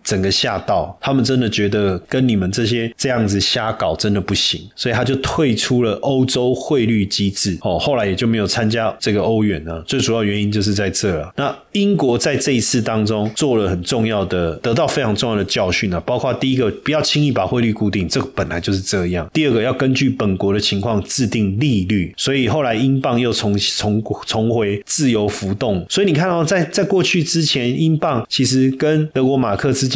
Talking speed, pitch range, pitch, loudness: 325 characters per minute, 100-135 Hz, 115 Hz, -17 LUFS